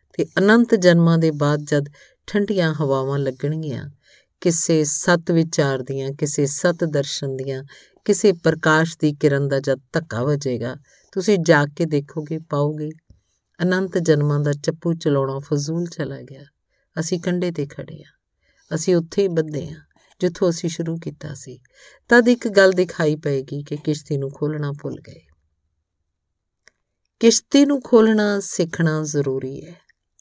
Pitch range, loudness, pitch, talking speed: 140-175 Hz, -20 LUFS, 155 Hz, 140 wpm